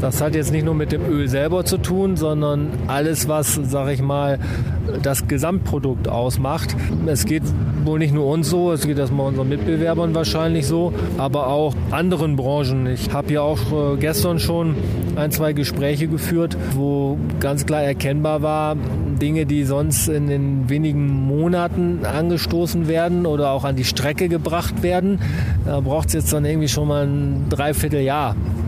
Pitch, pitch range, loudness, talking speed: 145 Hz, 135-155 Hz, -20 LUFS, 165 wpm